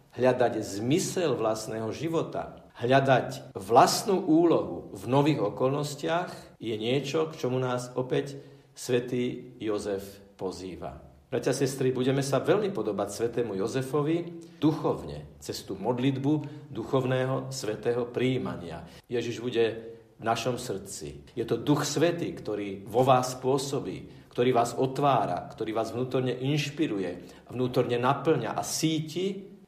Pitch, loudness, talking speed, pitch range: 130 Hz, -28 LUFS, 115 wpm, 115-145 Hz